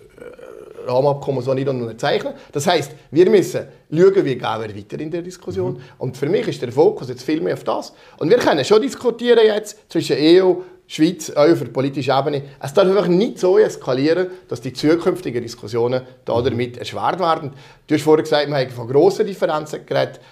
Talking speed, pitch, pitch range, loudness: 185 wpm, 165 Hz, 135-215 Hz, -18 LUFS